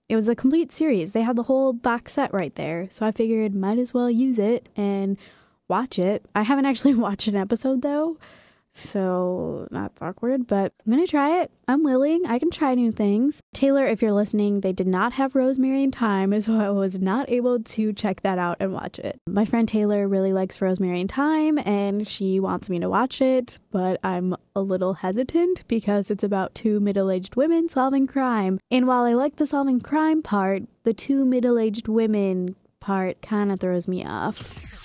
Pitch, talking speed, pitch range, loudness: 220 Hz, 200 wpm, 195-260 Hz, -23 LUFS